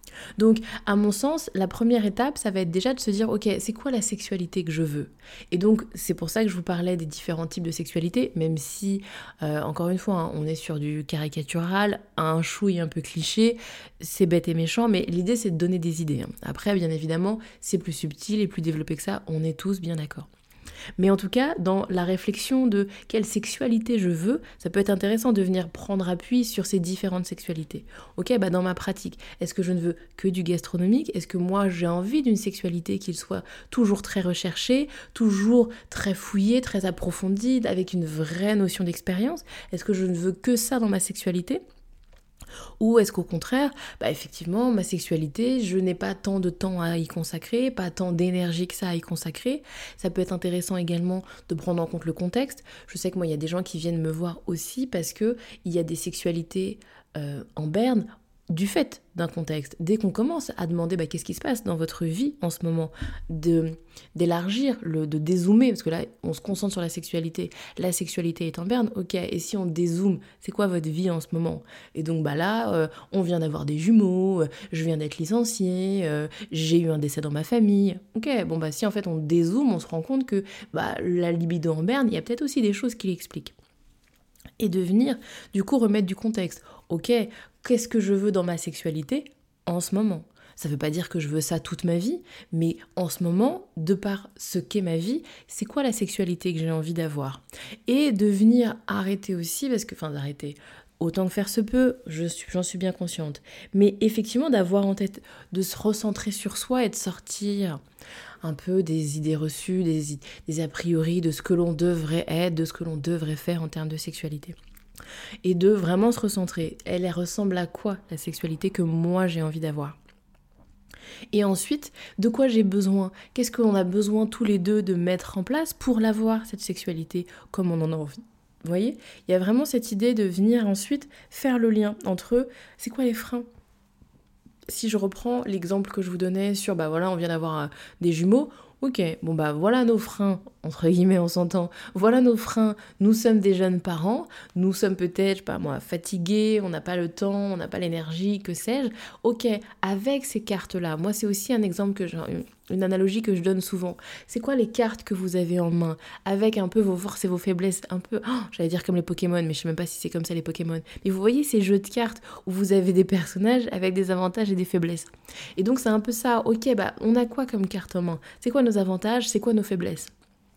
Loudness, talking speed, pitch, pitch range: -26 LUFS, 220 wpm, 190 Hz, 170-215 Hz